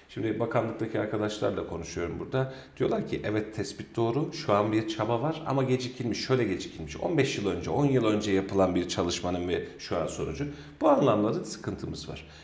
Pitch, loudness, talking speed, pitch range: 110 Hz, -29 LUFS, 180 wpm, 95-125 Hz